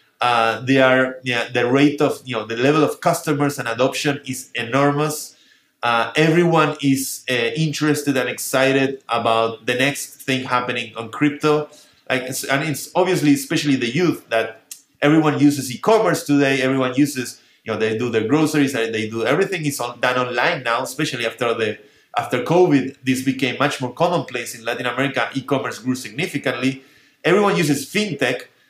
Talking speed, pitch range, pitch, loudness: 165 wpm, 125-145 Hz, 135 Hz, -19 LUFS